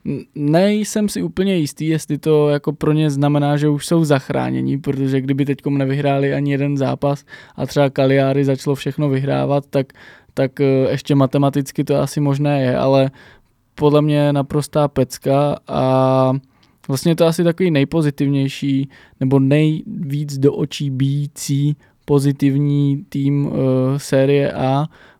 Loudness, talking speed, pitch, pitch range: -17 LUFS, 135 wpm, 140 Hz, 135-145 Hz